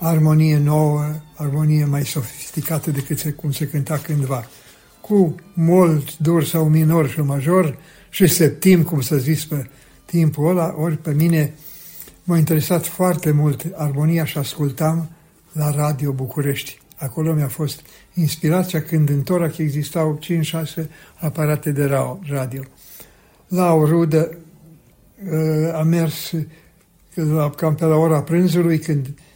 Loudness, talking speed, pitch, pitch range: -19 LUFS, 125 wpm, 155 Hz, 150-165 Hz